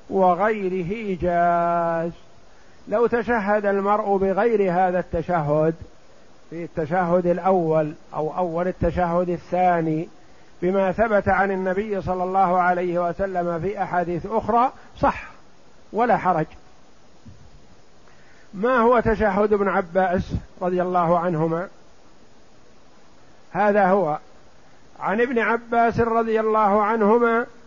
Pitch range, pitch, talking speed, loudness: 175-210 Hz, 185 Hz, 100 wpm, -21 LUFS